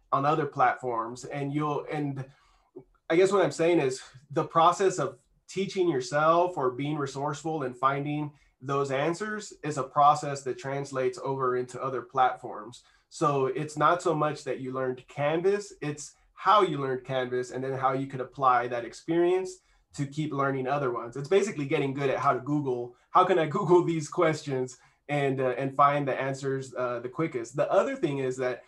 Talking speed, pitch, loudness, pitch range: 185 wpm, 140 Hz, -28 LUFS, 130-160 Hz